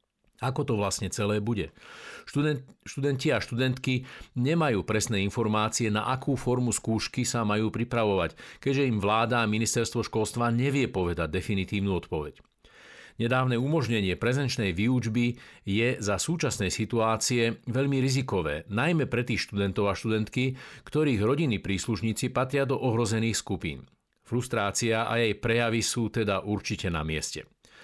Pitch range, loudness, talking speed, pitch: 105-125 Hz, -28 LUFS, 130 wpm, 115 Hz